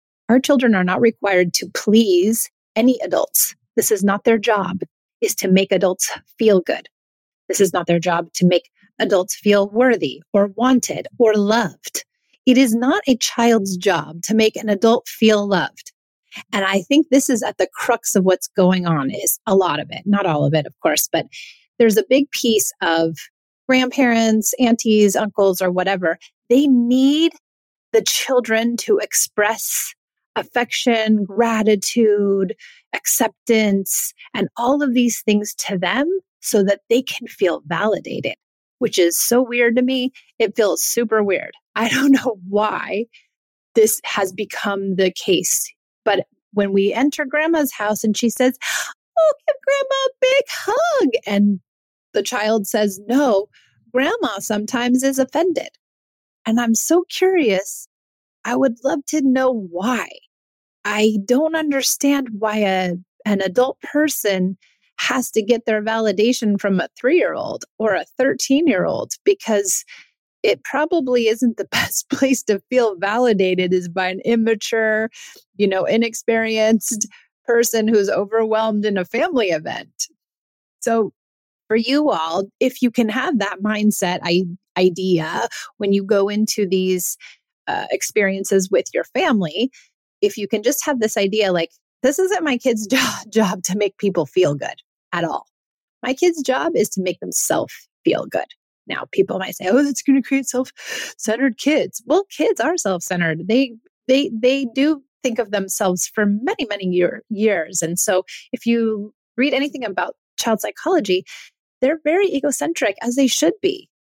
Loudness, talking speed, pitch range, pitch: -18 LUFS, 155 wpm, 200-265 Hz, 225 Hz